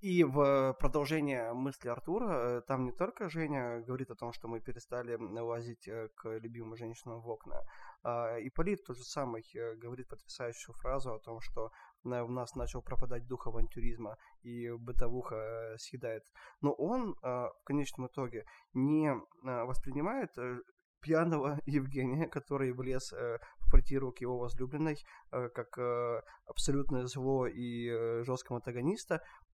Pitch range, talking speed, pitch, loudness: 120-140 Hz, 130 wpm, 125 Hz, -38 LUFS